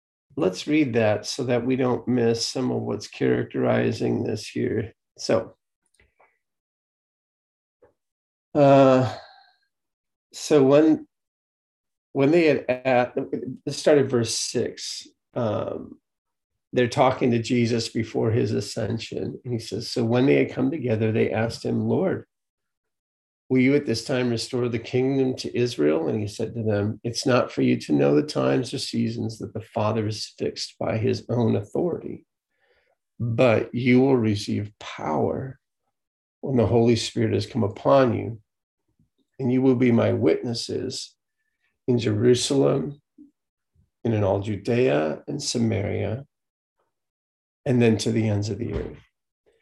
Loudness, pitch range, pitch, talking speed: -23 LUFS, 105-130 Hz, 115 Hz, 140 wpm